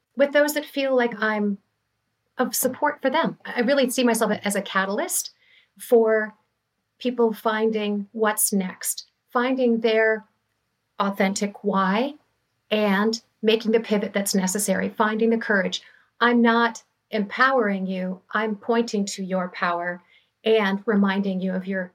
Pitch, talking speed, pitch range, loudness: 215 Hz, 135 wpm, 195-235 Hz, -23 LUFS